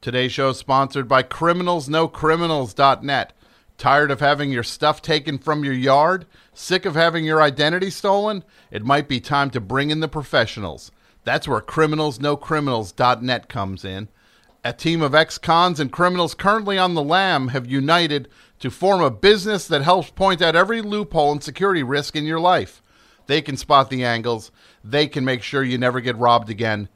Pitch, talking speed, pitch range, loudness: 150 Hz, 175 wpm, 130-170 Hz, -19 LUFS